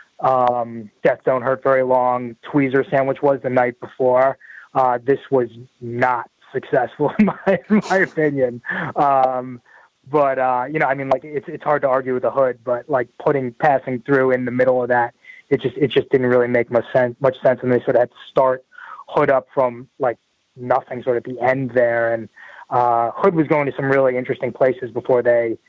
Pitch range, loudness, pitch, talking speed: 125-135 Hz, -19 LUFS, 130 Hz, 210 wpm